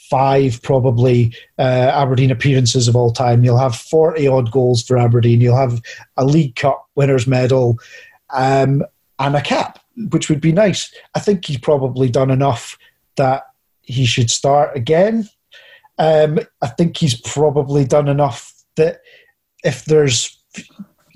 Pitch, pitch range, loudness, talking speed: 135 Hz, 125-155 Hz, -15 LUFS, 145 wpm